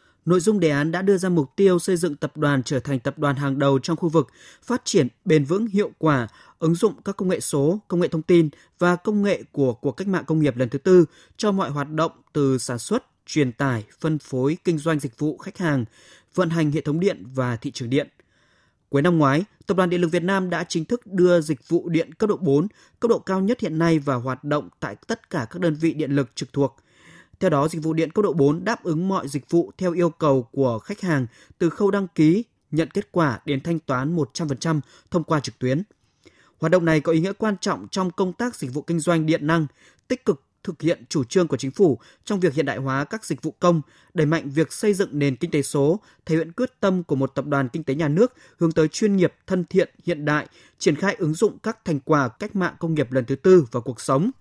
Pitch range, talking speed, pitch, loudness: 140-185 Hz, 255 wpm, 160 Hz, -22 LUFS